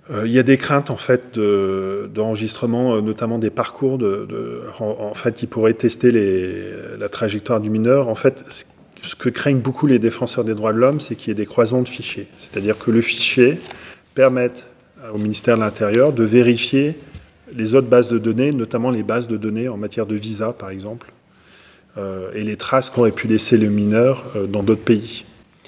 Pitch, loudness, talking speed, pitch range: 115 Hz, -18 LUFS, 200 wpm, 110-125 Hz